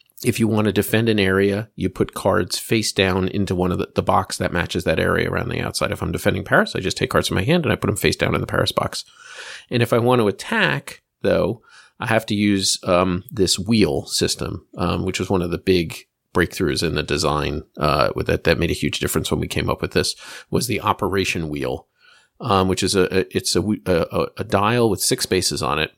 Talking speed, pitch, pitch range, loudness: 240 wpm, 95 Hz, 90-105 Hz, -20 LUFS